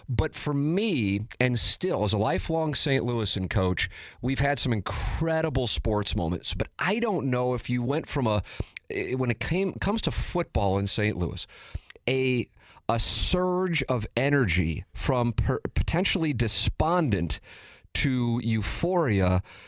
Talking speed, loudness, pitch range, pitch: 140 wpm, -27 LUFS, 105-145 Hz, 120 Hz